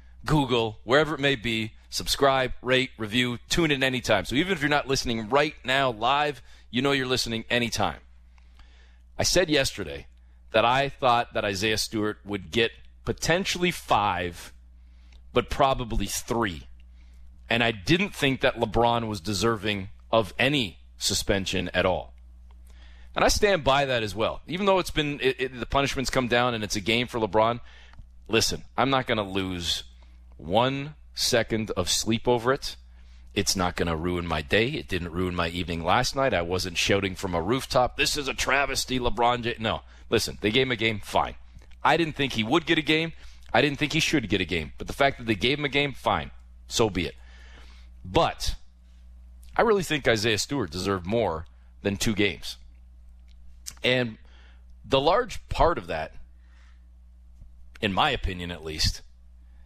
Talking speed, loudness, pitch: 175 wpm, -25 LUFS, 105 Hz